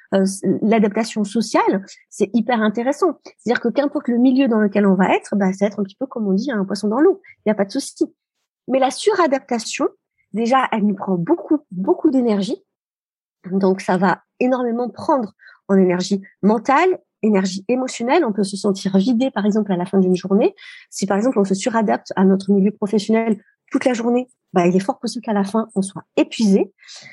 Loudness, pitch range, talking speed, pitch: -19 LUFS, 200-265 Hz, 205 wpm, 225 Hz